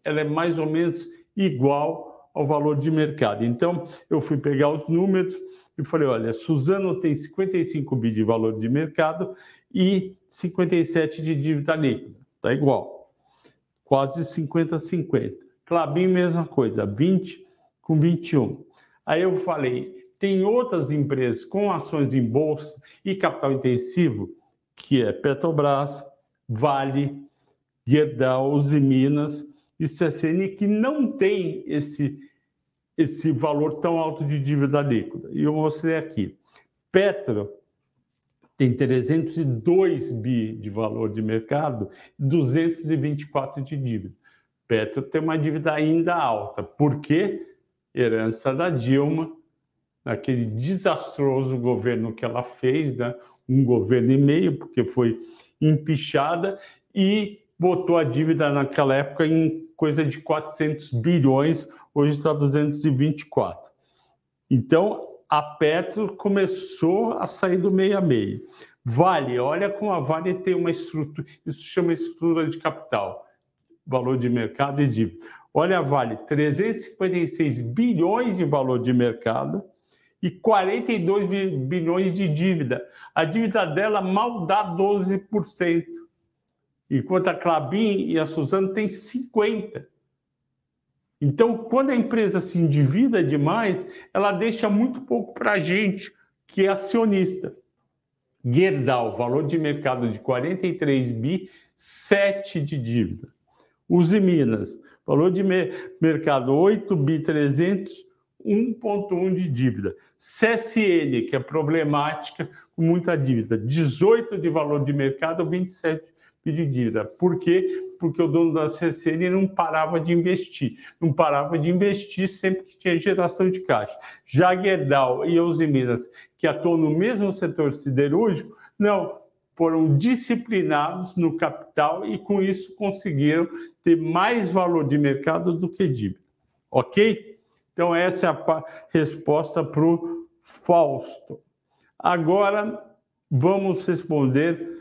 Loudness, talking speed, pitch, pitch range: -23 LUFS, 125 wpm, 160 Hz, 140-185 Hz